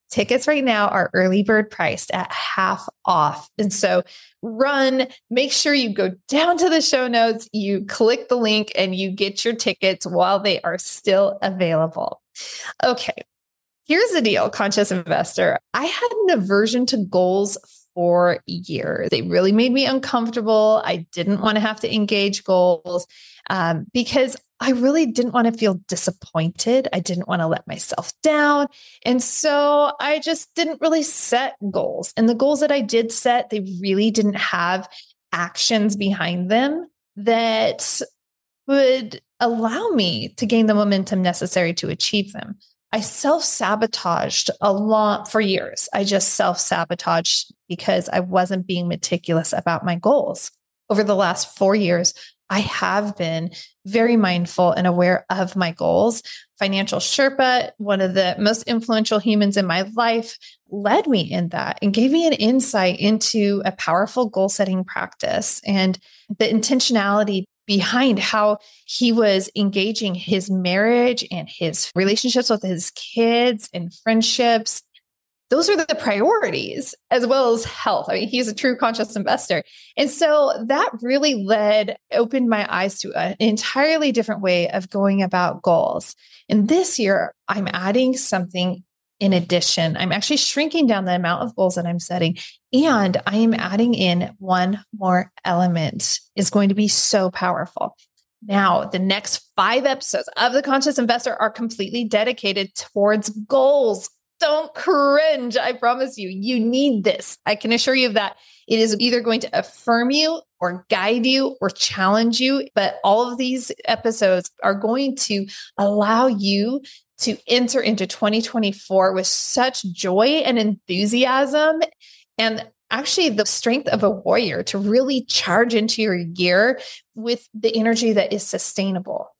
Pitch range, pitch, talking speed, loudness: 190-250 Hz, 215 Hz, 155 wpm, -19 LUFS